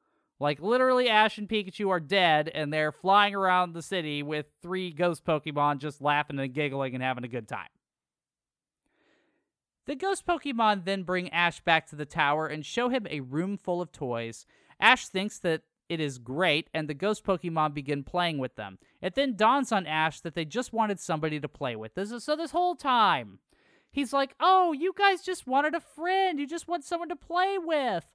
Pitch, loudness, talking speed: 185 Hz, -28 LUFS, 200 wpm